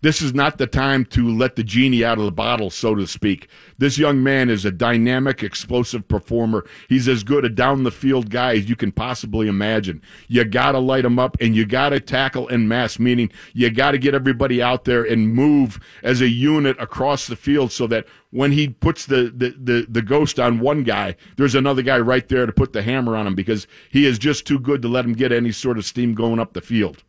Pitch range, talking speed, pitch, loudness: 115-135 Hz, 230 wpm, 125 Hz, -19 LUFS